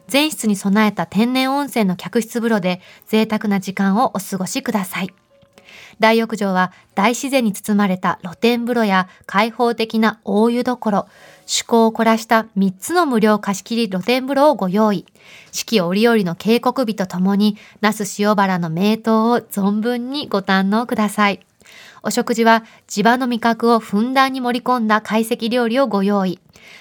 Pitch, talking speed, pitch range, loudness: 215 Hz, 305 characters per minute, 200-235 Hz, -18 LUFS